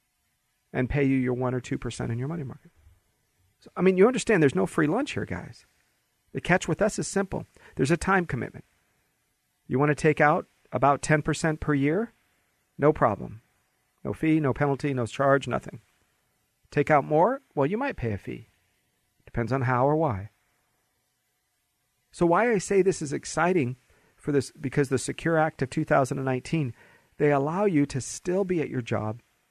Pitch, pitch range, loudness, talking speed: 145 Hz, 125-160 Hz, -26 LUFS, 180 wpm